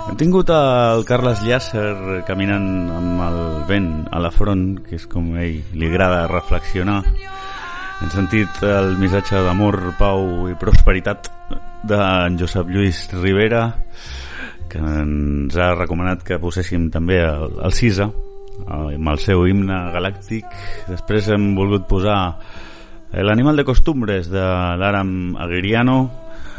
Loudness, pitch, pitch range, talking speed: -18 LUFS, 95 Hz, 90-105 Hz, 130 wpm